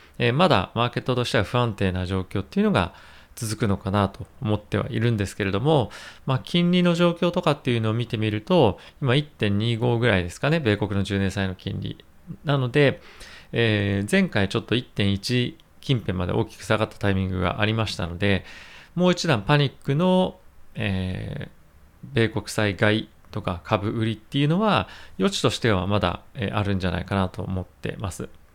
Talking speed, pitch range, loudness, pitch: 340 characters per minute, 95-130 Hz, -24 LUFS, 105 Hz